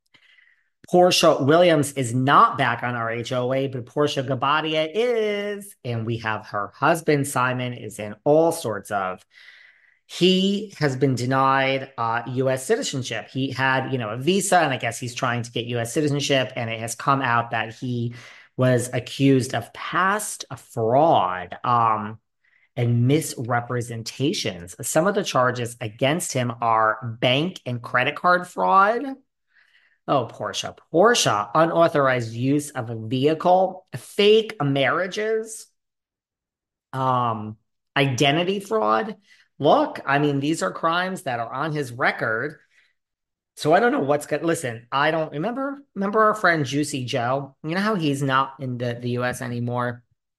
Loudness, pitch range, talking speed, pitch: -22 LUFS, 120-160 Hz, 145 wpm, 135 Hz